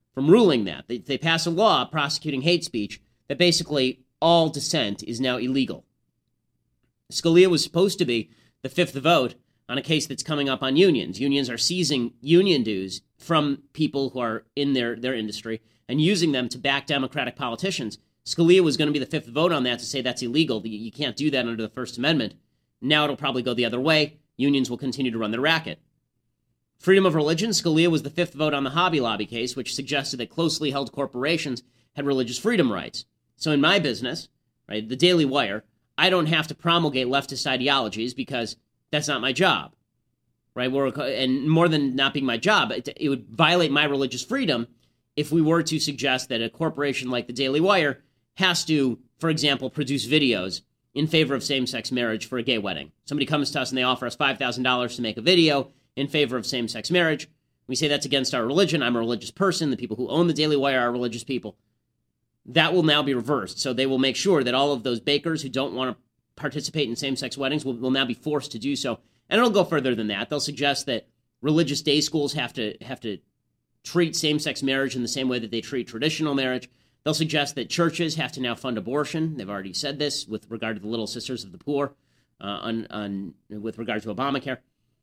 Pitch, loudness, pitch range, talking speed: 135 Hz, -24 LUFS, 120-150 Hz, 215 wpm